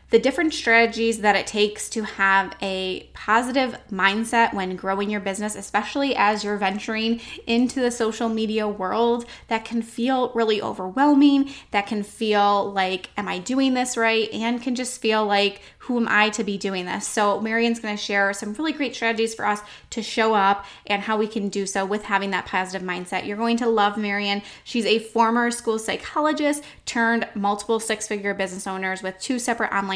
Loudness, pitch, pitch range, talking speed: -22 LUFS, 215 Hz, 200-230 Hz, 190 wpm